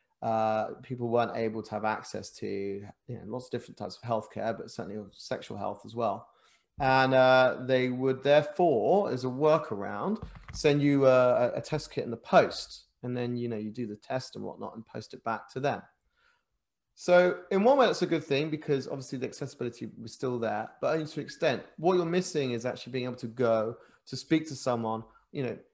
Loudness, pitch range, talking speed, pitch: -29 LUFS, 115-145 Hz, 210 wpm, 130 Hz